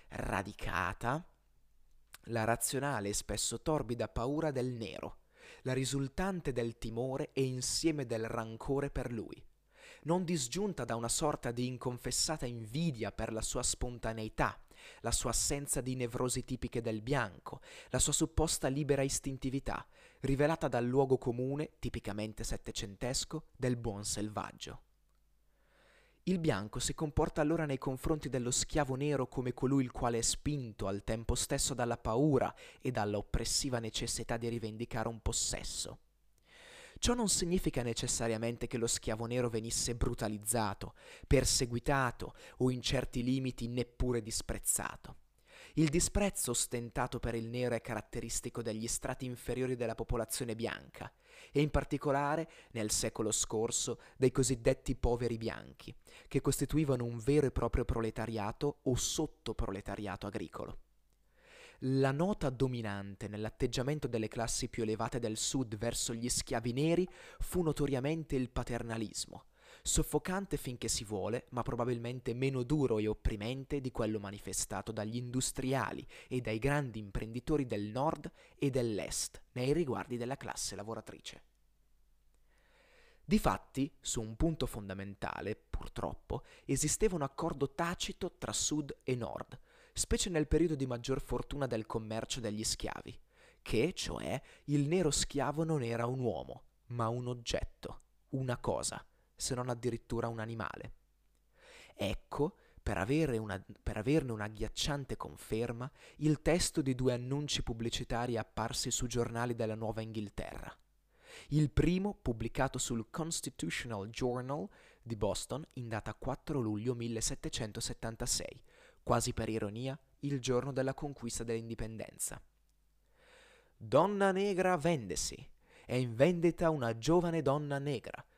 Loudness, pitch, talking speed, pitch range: -36 LUFS, 125 Hz, 130 wpm, 115-140 Hz